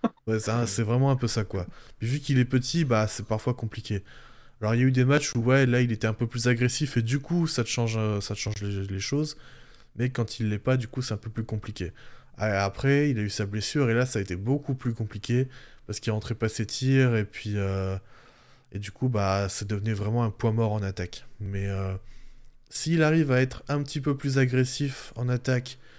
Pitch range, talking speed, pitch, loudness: 105-130 Hz, 245 wpm, 120 Hz, -27 LUFS